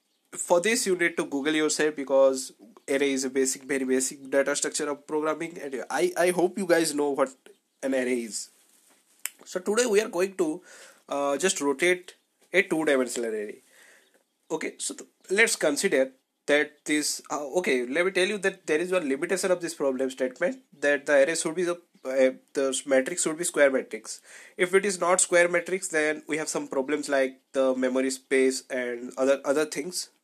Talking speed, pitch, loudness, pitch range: 190 wpm, 155 Hz, -26 LUFS, 135-180 Hz